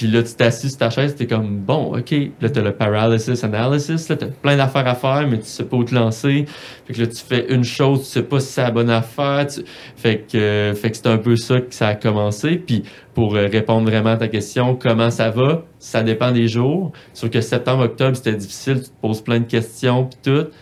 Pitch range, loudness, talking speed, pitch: 115-135 Hz, -18 LUFS, 245 wpm, 120 Hz